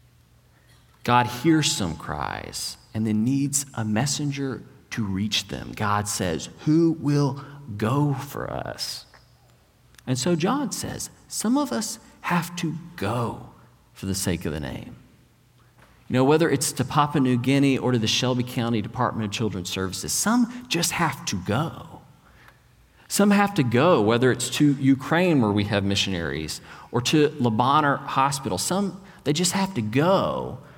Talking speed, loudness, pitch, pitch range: 155 wpm, -24 LUFS, 130 Hz, 110-155 Hz